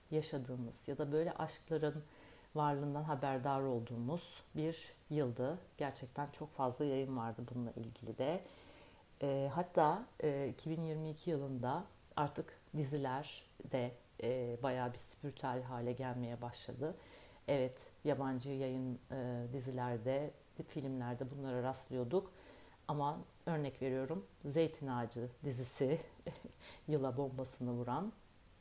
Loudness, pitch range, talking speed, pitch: -41 LUFS, 125-150 Hz, 105 wpm, 135 Hz